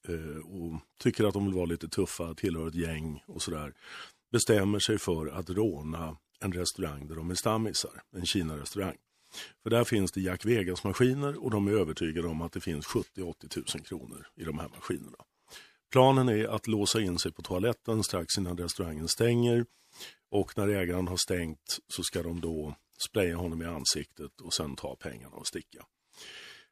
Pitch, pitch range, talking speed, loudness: 90 Hz, 85-110 Hz, 175 wpm, -31 LUFS